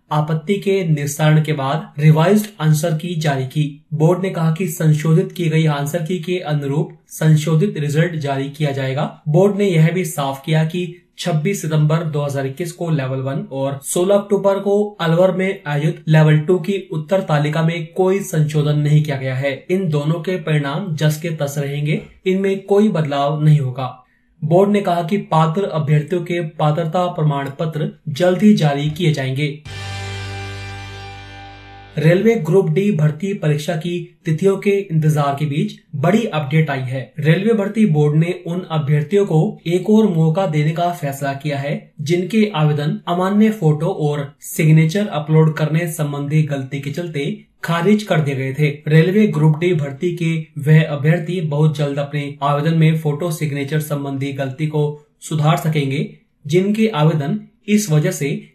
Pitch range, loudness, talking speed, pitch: 145-180 Hz, -17 LUFS, 160 wpm, 160 Hz